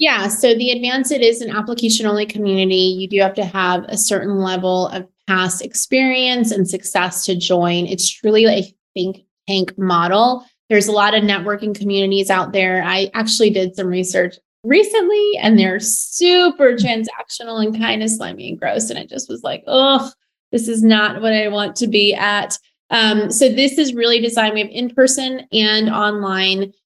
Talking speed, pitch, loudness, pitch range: 185 wpm, 210 Hz, -16 LUFS, 190-235 Hz